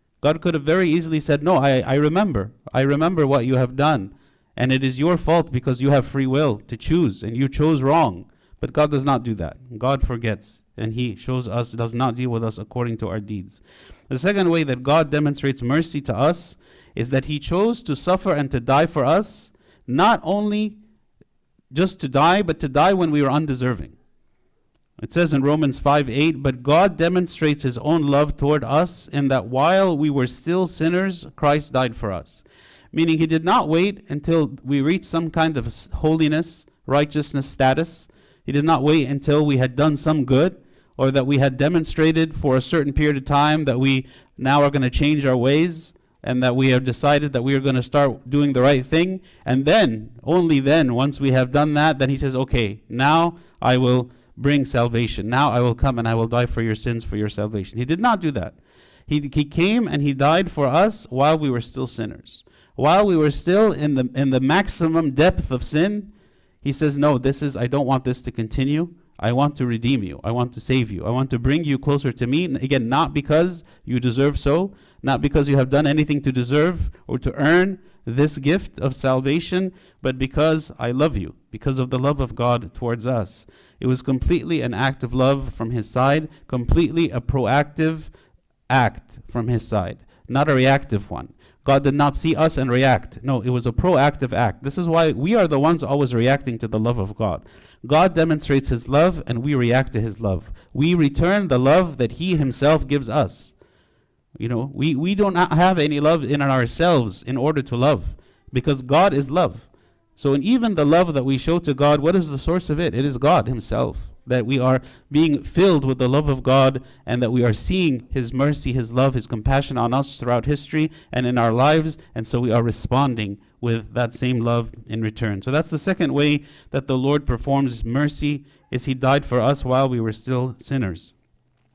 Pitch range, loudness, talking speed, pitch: 125-155 Hz, -20 LUFS, 210 wpm, 140 Hz